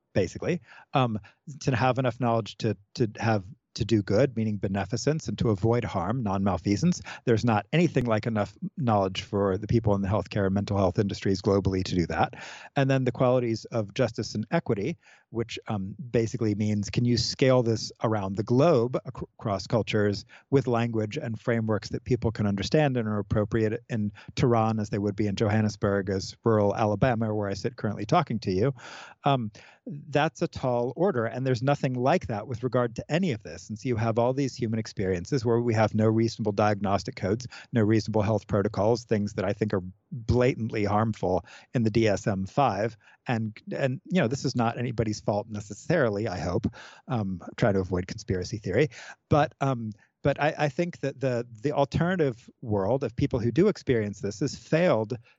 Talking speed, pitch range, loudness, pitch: 190 wpm, 105-130 Hz, -27 LUFS, 115 Hz